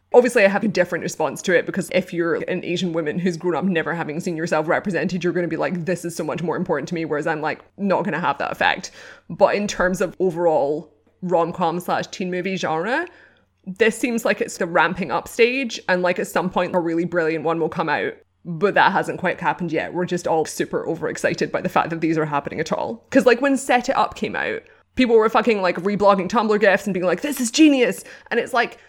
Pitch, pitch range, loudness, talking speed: 180 Hz, 165-215 Hz, -21 LUFS, 245 wpm